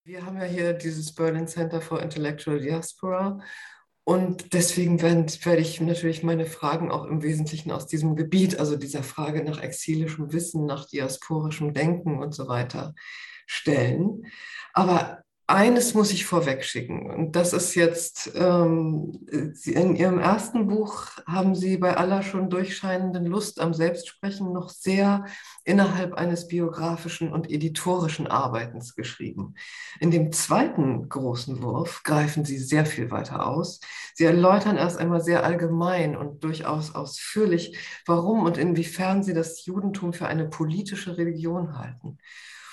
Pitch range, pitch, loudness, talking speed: 155-180 Hz, 170 Hz, -25 LUFS, 140 wpm